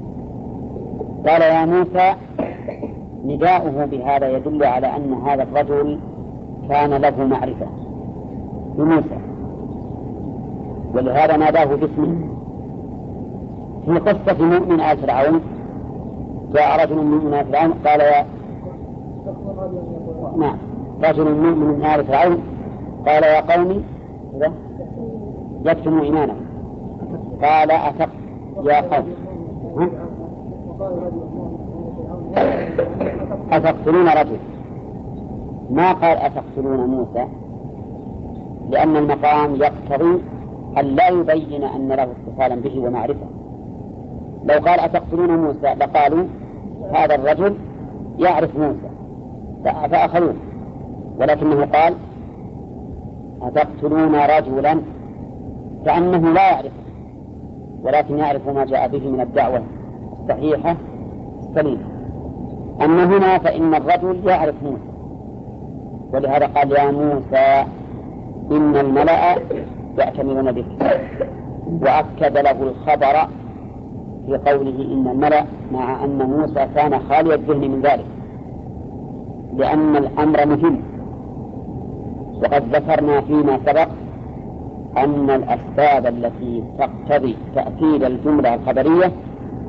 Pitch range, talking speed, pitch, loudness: 135-155 Hz, 85 wpm, 145 Hz, -17 LUFS